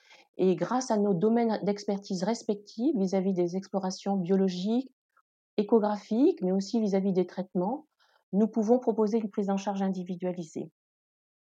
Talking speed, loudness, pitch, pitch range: 130 wpm, -29 LUFS, 205 Hz, 190-225 Hz